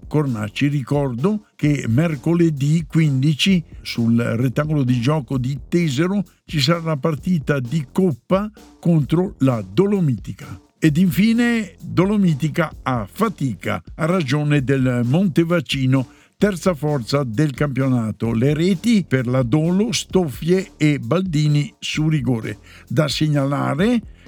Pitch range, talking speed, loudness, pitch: 135-175 Hz, 110 wpm, -19 LUFS, 150 Hz